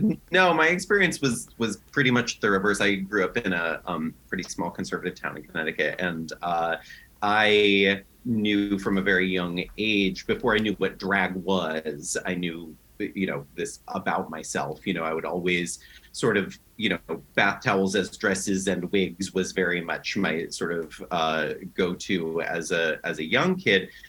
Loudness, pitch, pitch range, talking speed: -25 LUFS, 95 Hz, 90-105 Hz, 180 wpm